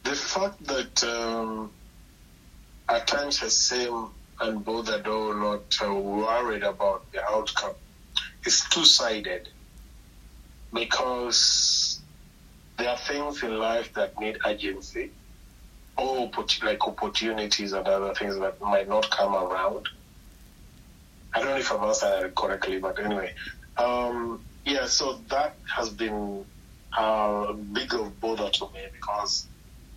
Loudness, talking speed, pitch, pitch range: -26 LUFS, 125 wpm, 105 Hz, 100-115 Hz